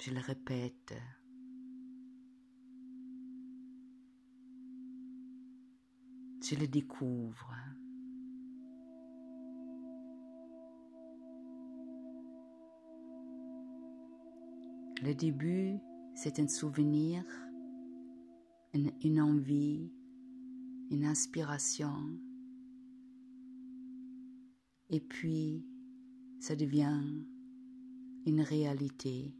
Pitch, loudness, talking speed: 150 Hz, -38 LUFS, 45 wpm